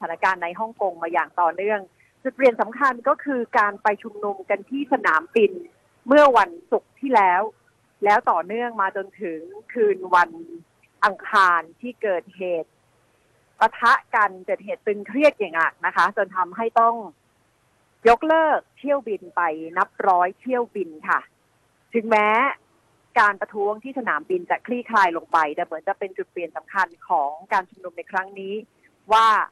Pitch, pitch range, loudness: 205 Hz, 175-235 Hz, -21 LUFS